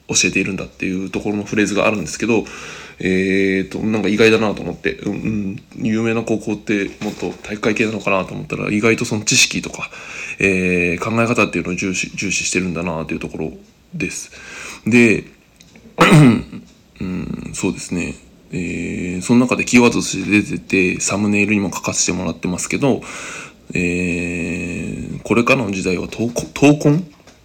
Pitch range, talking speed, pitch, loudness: 90-115 Hz, 350 characters per minute, 100 Hz, -17 LUFS